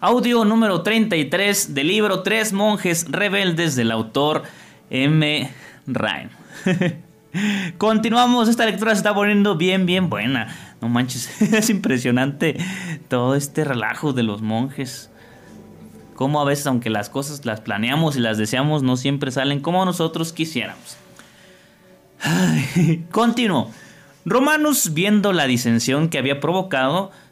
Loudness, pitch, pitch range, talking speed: -19 LUFS, 160 Hz, 135-200 Hz, 125 wpm